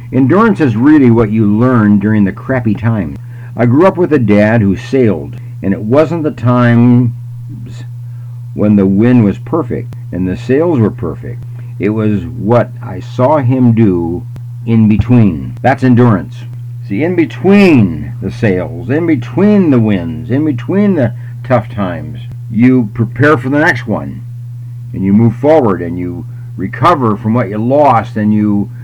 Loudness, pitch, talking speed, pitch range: -11 LUFS, 120 Hz, 160 wpm, 110-125 Hz